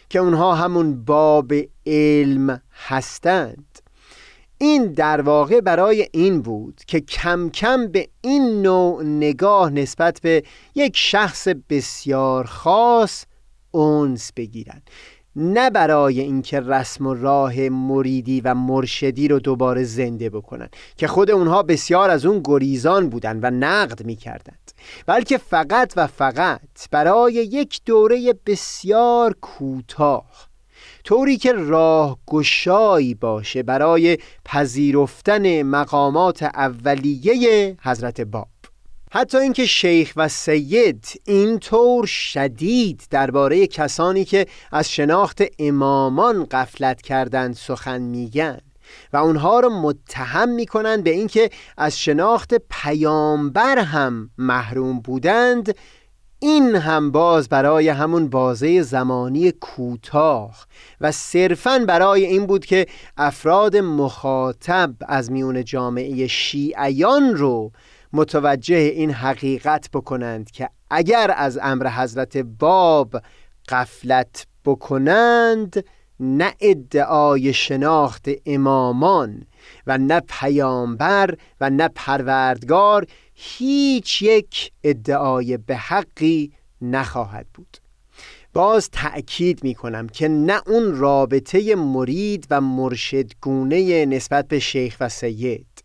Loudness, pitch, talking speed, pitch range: -18 LUFS, 150 Hz, 105 wpm, 130-185 Hz